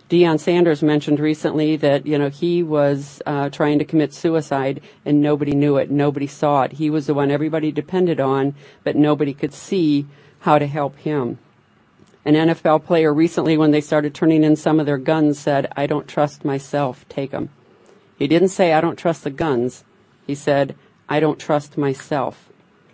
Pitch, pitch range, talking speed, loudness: 150 Hz, 145-155 Hz, 185 wpm, -19 LUFS